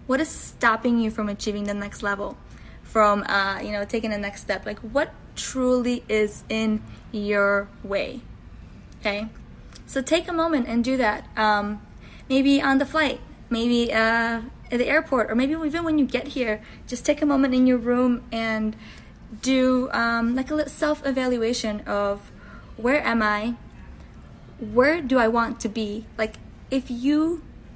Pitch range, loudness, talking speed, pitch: 215-265 Hz, -23 LUFS, 165 wpm, 235 Hz